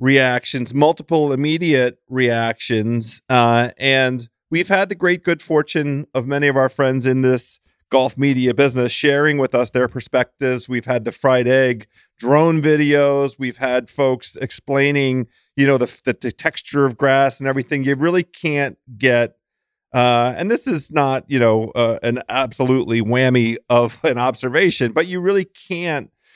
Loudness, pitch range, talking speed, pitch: -17 LUFS, 125-145 Hz, 160 wpm, 130 Hz